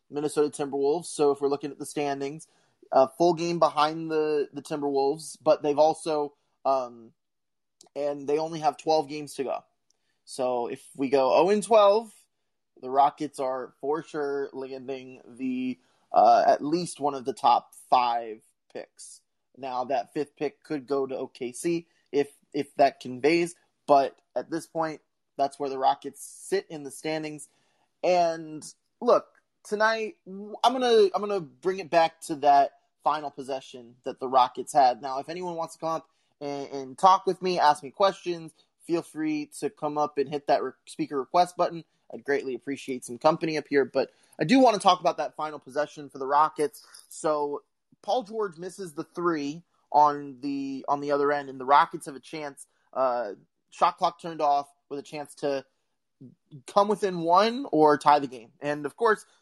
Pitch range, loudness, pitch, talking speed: 140-170 Hz, -26 LUFS, 150 Hz, 175 wpm